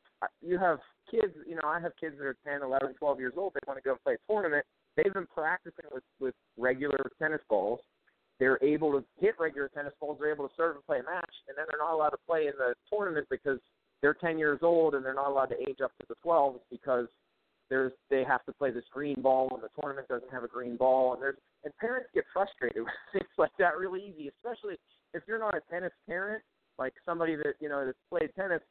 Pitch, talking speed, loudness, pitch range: 145 Hz, 240 wpm, -32 LUFS, 135-175 Hz